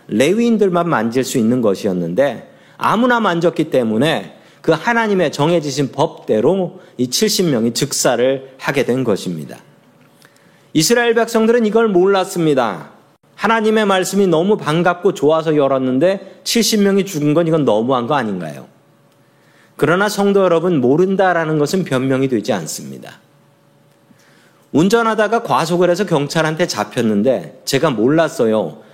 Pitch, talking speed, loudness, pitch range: 175 Hz, 305 characters per minute, -15 LUFS, 145-200 Hz